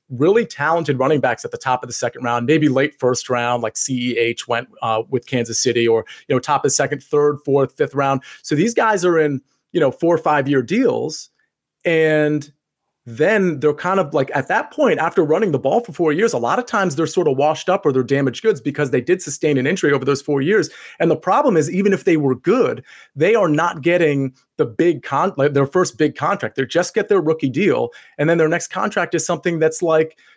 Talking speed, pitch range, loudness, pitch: 235 wpm, 135-170 Hz, -18 LUFS, 150 Hz